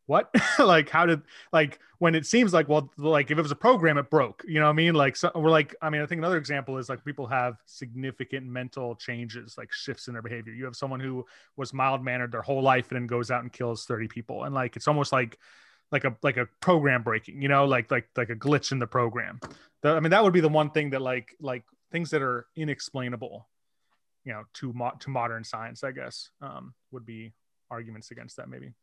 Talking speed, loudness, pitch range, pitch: 240 wpm, -26 LUFS, 120-150 Hz, 135 Hz